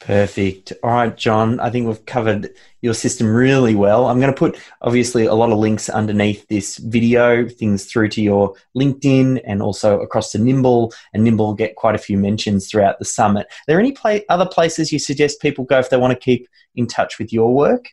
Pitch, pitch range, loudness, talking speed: 115 Hz, 105-130 Hz, -17 LUFS, 220 wpm